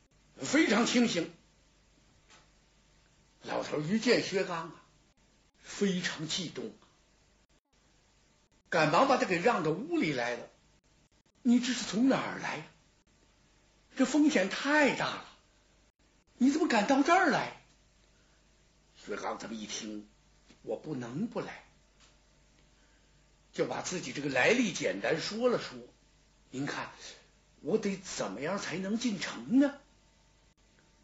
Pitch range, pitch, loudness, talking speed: 165-260 Hz, 215 Hz, -31 LUFS, 160 characters per minute